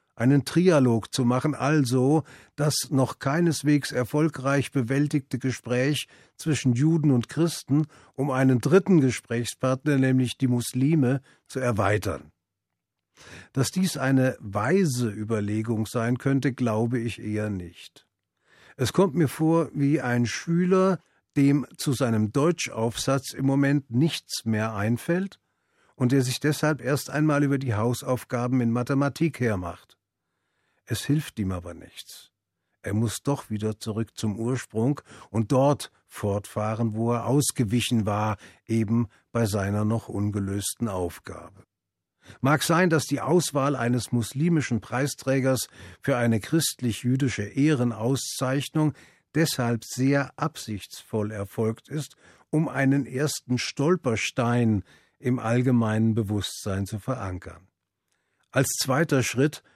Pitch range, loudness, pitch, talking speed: 110-140 Hz, -25 LUFS, 125 Hz, 120 wpm